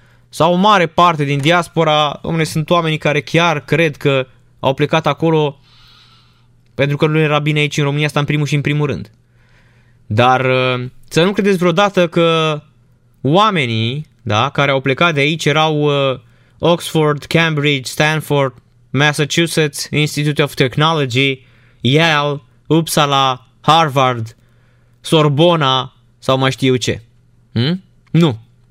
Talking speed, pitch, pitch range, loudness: 130 wpm, 145 Hz, 125-155 Hz, -14 LUFS